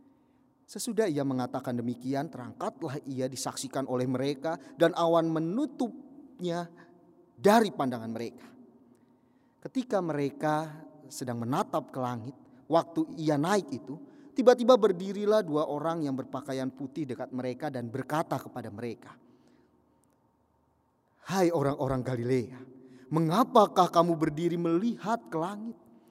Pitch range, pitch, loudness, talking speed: 130-195 Hz, 155 Hz, -30 LUFS, 110 wpm